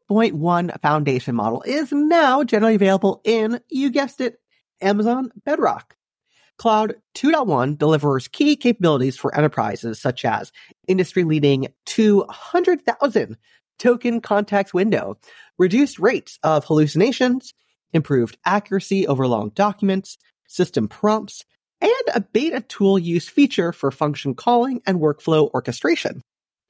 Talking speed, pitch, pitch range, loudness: 115 wpm, 200 Hz, 155-240 Hz, -19 LUFS